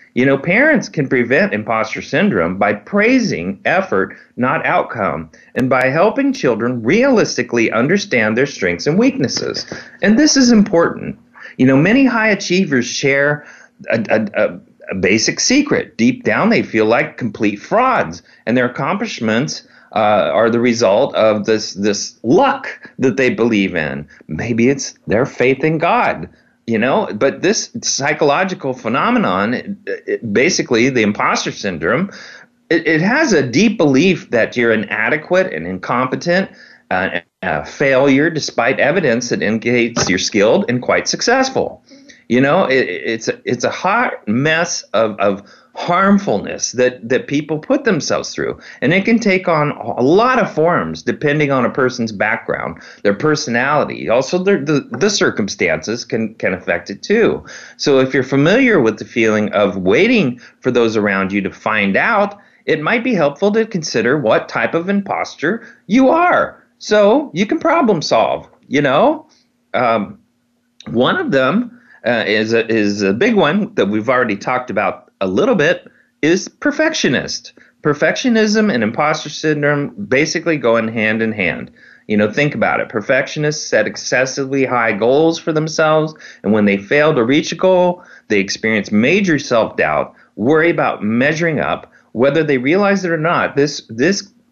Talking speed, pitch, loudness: 155 wpm, 155 Hz, -15 LUFS